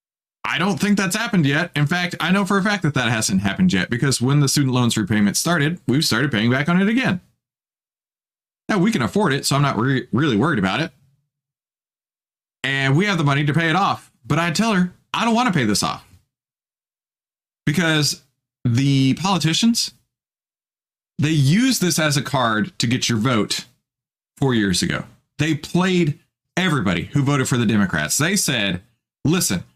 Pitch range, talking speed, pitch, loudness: 125-175 Hz, 185 wpm, 145 Hz, -19 LUFS